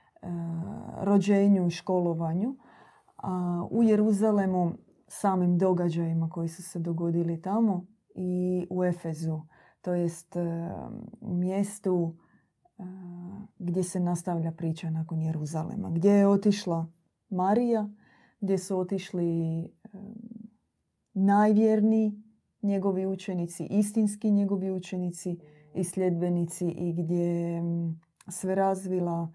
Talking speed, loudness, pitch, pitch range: 90 wpm, -28 LUFS, 185 Hz, 170-200 Hz